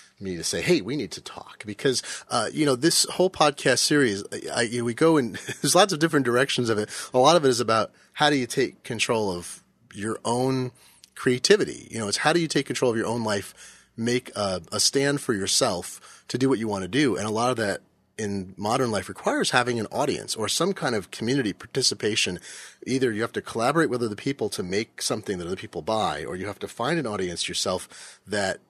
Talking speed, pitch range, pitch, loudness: 235 wpm, 110-140 Hz, 125 Hz, -24 LUFS